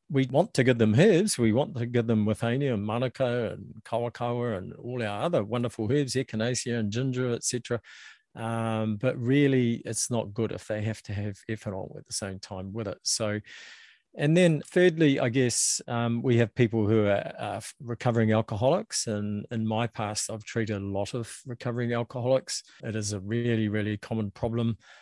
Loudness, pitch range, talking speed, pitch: -28 LUFS, 110-125 Hz, 185 wpm, 115 Hz